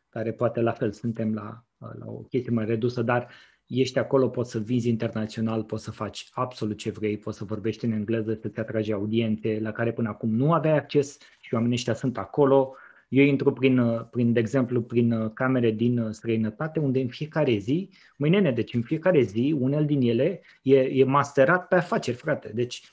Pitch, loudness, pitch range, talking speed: 120 Hz, -25 LUFS, 110-135 Hz, 195 wpm